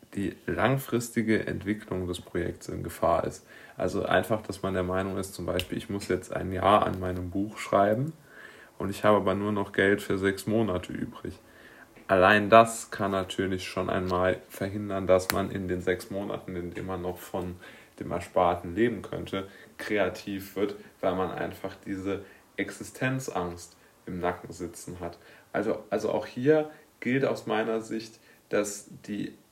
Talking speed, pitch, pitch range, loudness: 165 wpm, 100 Hz, 90-110 Hz, -29 LUFS